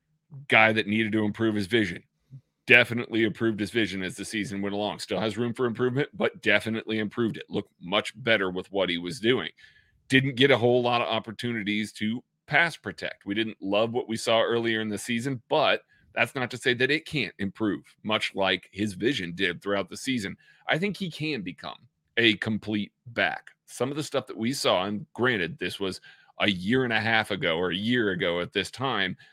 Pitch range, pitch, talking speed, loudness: 100-125 Hz, 110 Hz, 210 wpm, -26 LUFS